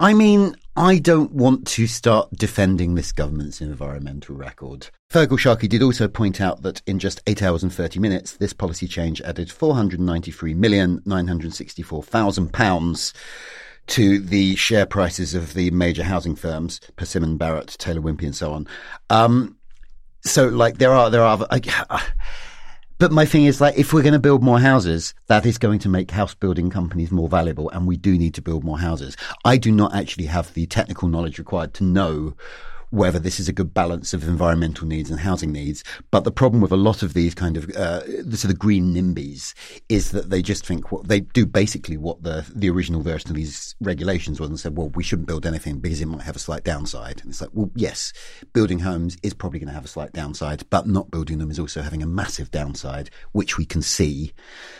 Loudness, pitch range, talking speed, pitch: -20 LUFS, 80-105 Hz, 210 wpm, 90 Hz